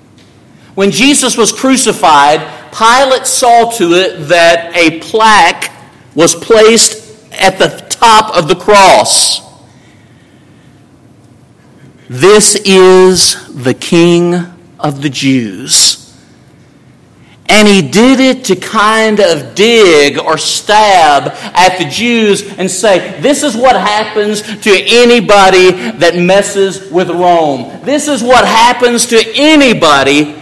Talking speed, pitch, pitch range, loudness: 110 wpm, 195 Hz, 170-225 Hz, -7 LUFS